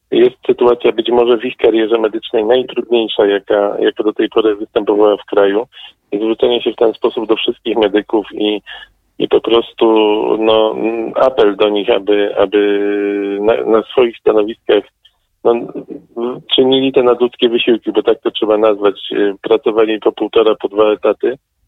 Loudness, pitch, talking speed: -13 LUFS, 115 Hz, 150 wpm